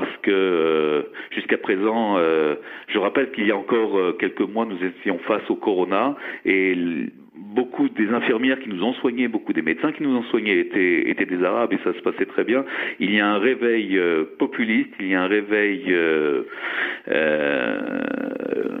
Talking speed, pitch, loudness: 175 wpm, 115 Hz, -22 LUFS